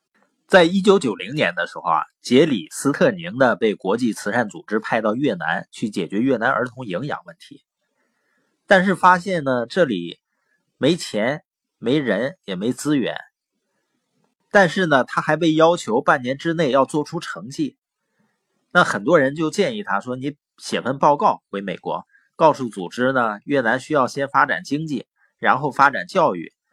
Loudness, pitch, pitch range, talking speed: -20 LUFS, 165 Hz, 135-190 Hz, 240 characters per minute